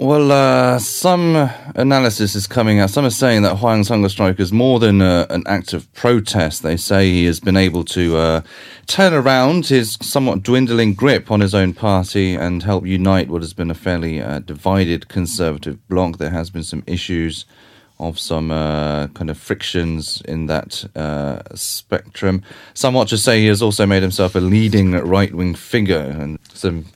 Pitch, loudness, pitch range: 95 Hz, -16 LUFS, 85-115 Hz